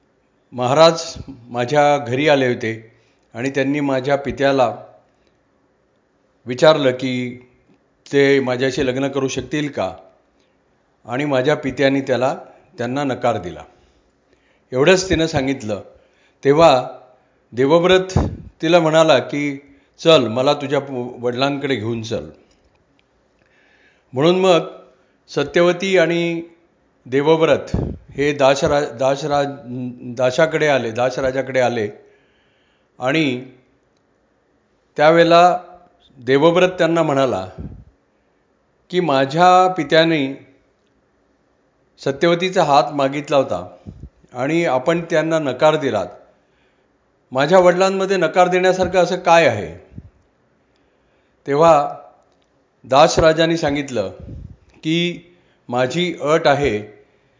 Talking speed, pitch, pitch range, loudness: 85 wpm, 140 Hz, 125-165 Hz, -17 LUFS